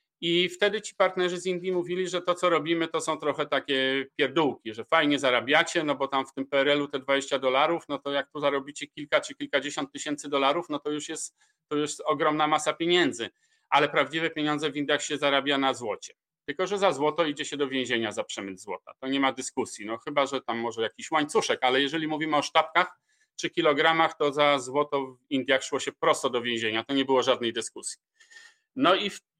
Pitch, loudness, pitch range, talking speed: 150 Hz, -26 LUFS, 135-170 Hz, 210 wpm